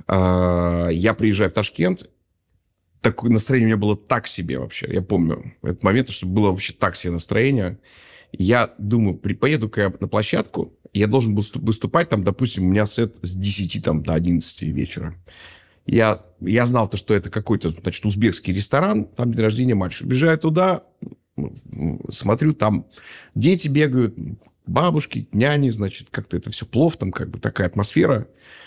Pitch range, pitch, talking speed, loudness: 95-120 Hz, 105 Hz, 160 wpm, -21 LUFS